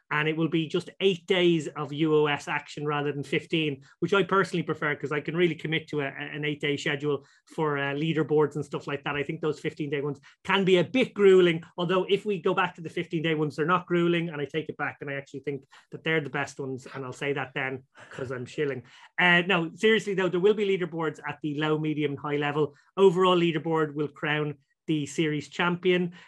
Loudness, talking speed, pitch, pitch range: -27 LUFS, 225 wpm, 155 Hz, 145-175 Hz